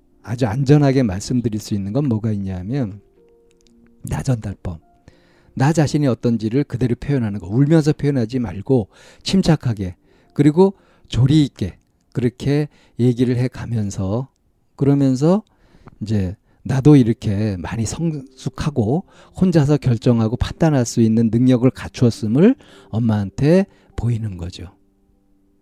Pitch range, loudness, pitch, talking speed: 105-140 Hz, -18 LUFS, 120 Hz, 275 characters per minute